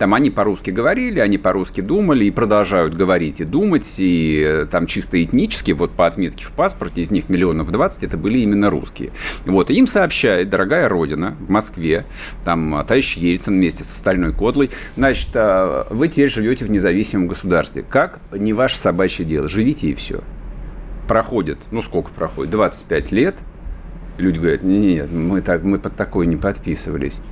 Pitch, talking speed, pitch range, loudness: 95 Hz, 165 wpm, 85-105 Hz, -17 LUFS